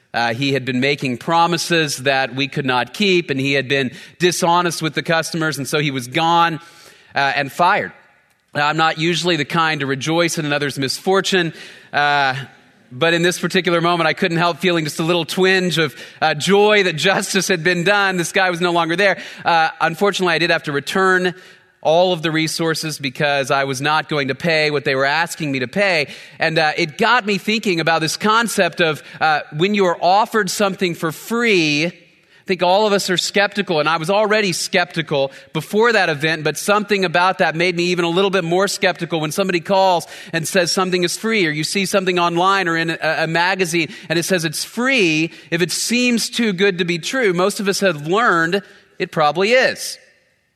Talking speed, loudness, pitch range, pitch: 210 wpm, -17 LUFS, 155-190 Hz, 170 Hz